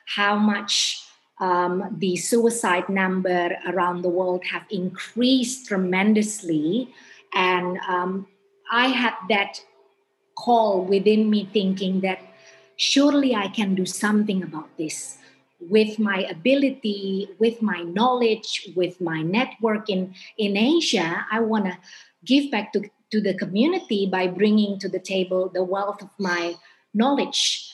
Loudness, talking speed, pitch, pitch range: -22 LUFS, 130 wpm, 200 Hz, 185-220 Hz